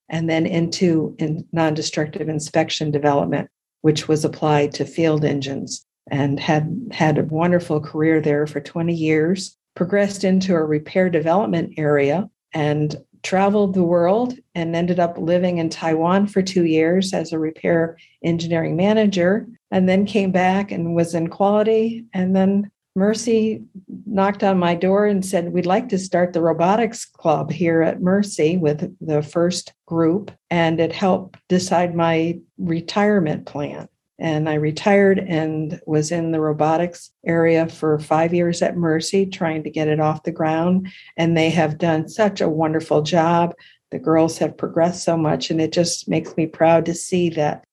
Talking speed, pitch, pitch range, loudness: 160 wpm, 170 Hz, 160-185 Hz, -19 LUFS